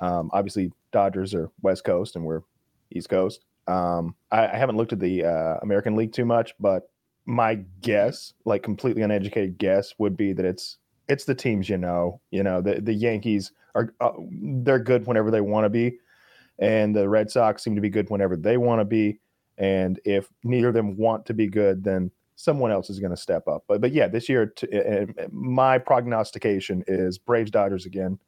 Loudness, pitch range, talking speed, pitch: -24 LUFS, 95-115 Hz, 200 wpm, 105 Hz